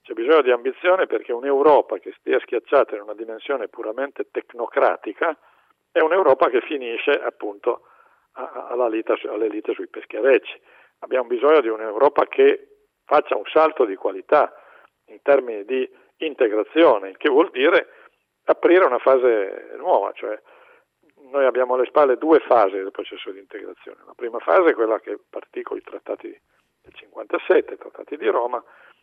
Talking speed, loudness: 150 wpm, -20 LUFS